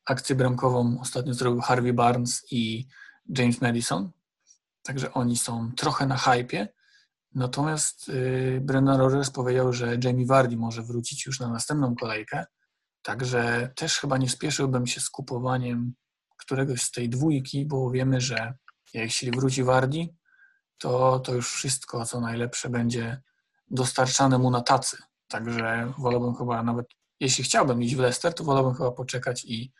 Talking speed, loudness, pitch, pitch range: 145 wpm, -26 LUFS, 125 Hz, 120-135 Hz